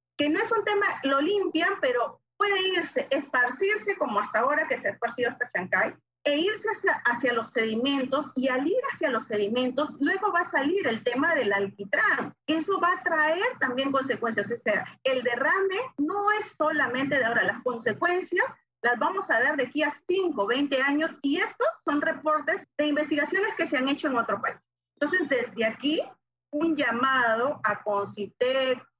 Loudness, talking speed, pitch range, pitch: -26 LUFS, 180 wpm, 250-350 Hz, 295 Hz